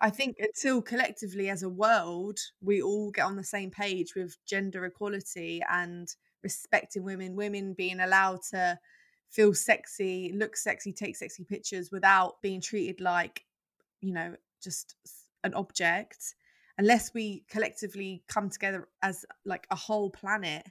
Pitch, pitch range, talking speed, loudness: 195 Hz, 185-210 Hz, 145 wpm, -30 LUFS